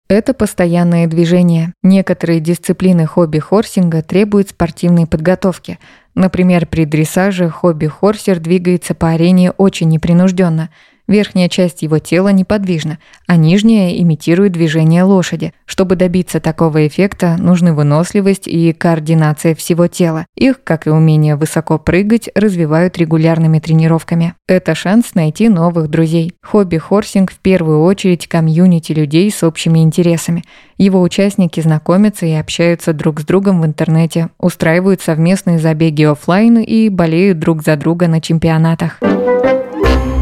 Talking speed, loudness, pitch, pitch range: 120 wpm, -12 LUFS, 170 Hz, 160-185 Hz